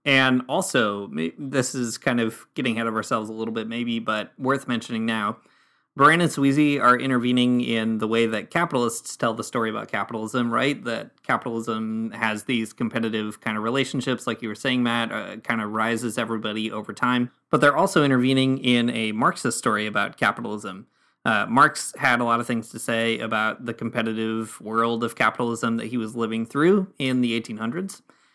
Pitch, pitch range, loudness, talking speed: 115 Hz, 110-125 Hz, -23 LUFS, 185 wpm